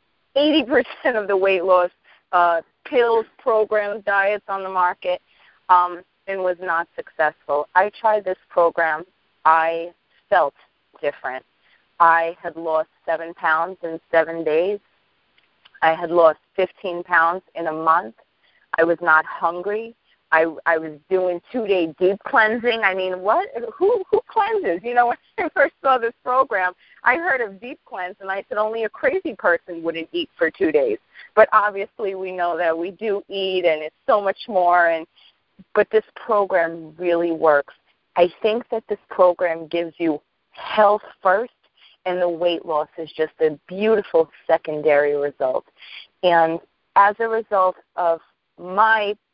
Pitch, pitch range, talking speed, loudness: 185 Hz, 165-215 Hz, 155 wpm, -20 LUFS